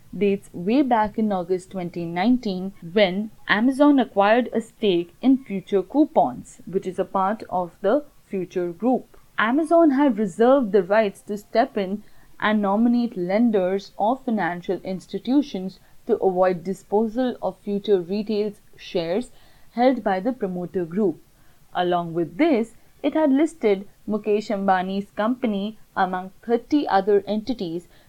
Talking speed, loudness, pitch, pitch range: 130 wpm, -22 LUFS, 205 Hz, 190-235 Hz